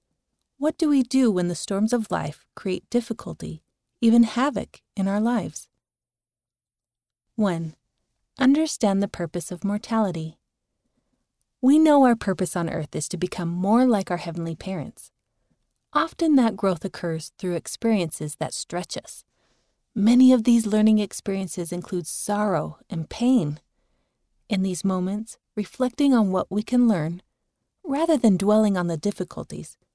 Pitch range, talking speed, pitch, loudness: 180-240 Hz, 140 wpm, 205 Hz, -23 LUFS